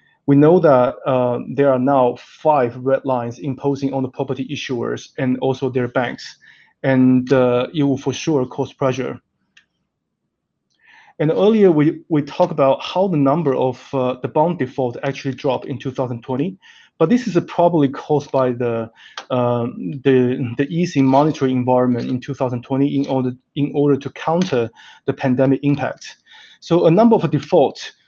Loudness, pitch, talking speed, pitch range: -18 LUFS, 135 Hz, 160 wpm, 130-145 Hz